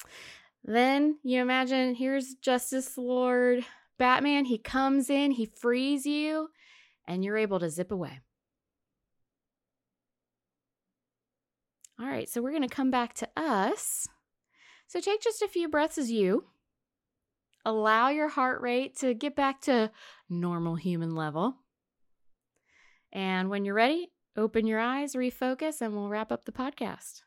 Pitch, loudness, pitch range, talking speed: 255 Hz, -29 LUFS, 220-280 Hz, 135 wpm